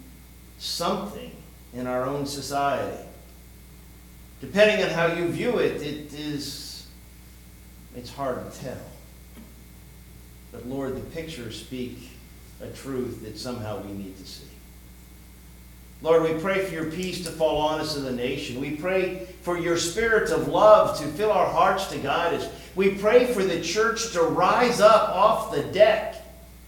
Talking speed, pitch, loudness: 155 wpm, 130 Hz, -24 LUFS